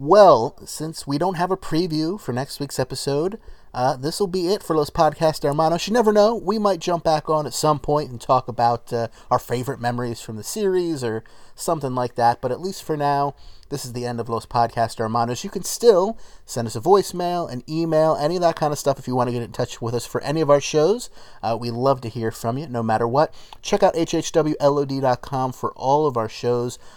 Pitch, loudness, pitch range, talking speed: 140 Hz, -21 LUFS, 120-165 Hz, 235 wpm